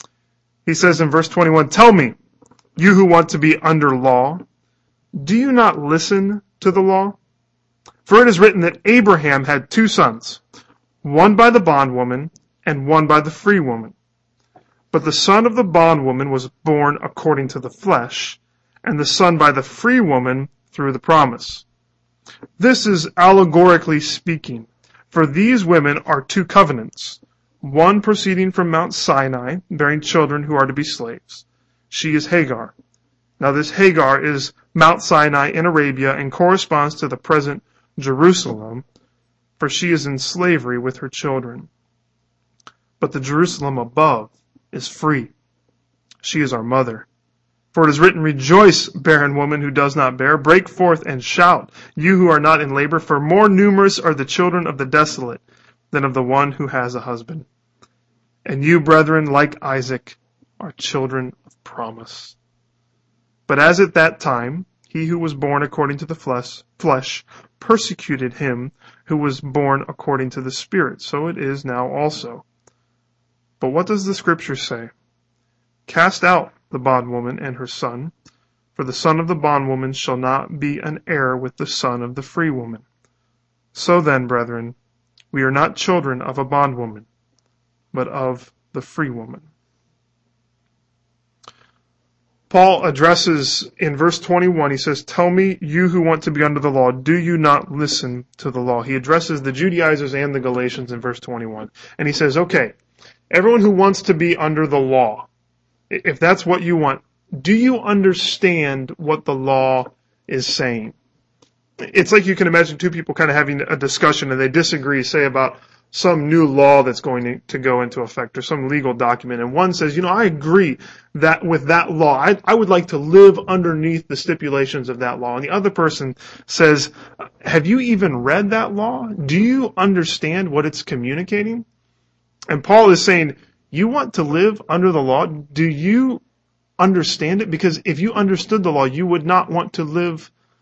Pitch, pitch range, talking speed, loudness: 150 Hz, 130-175 Hz, 170 wpm, -16 LUFS